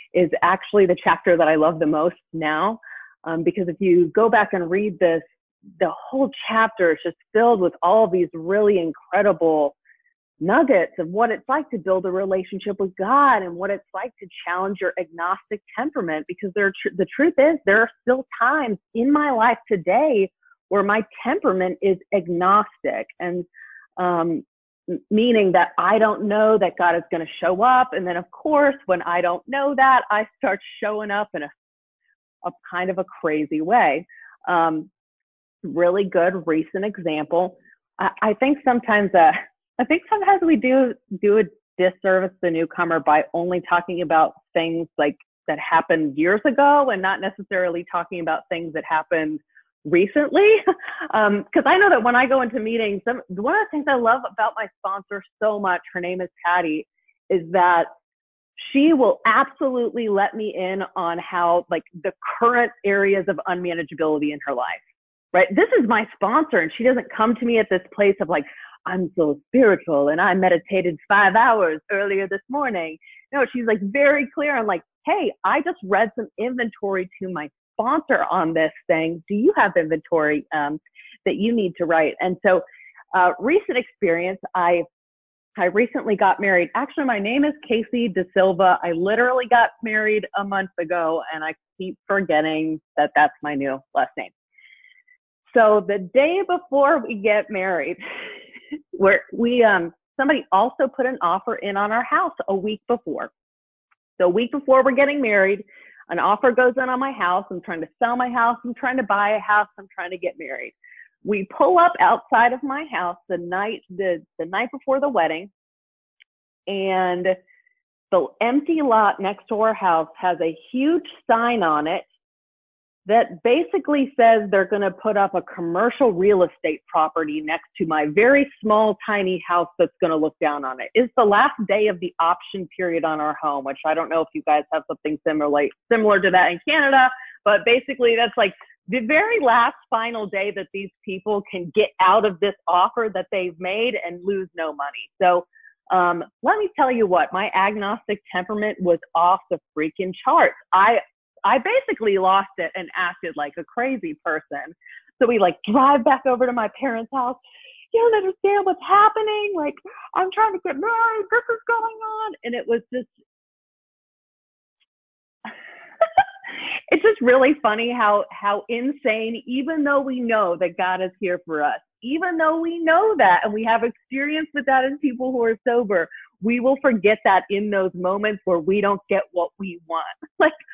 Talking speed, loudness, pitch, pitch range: 180 wpm, -20 LUFS, 205 Hz, 180-255 Hz